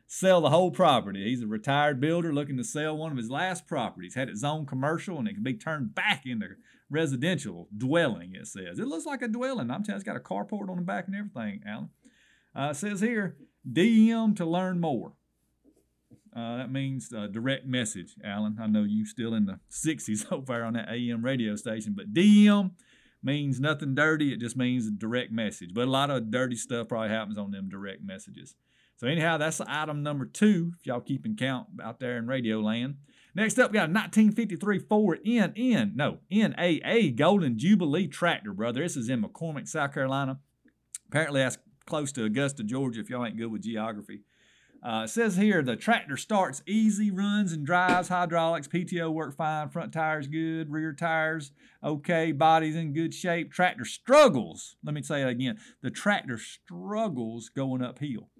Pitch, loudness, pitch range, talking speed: 155 Hz, -28 LUFS, 125-190 Hz, 190 wpm